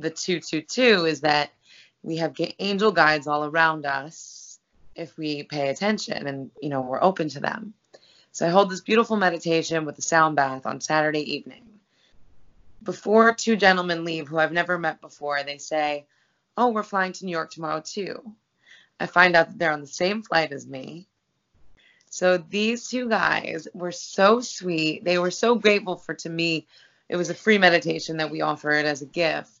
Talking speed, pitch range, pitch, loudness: 185 wpm, 155-195 Hz, 165 Hz, -23 LUFS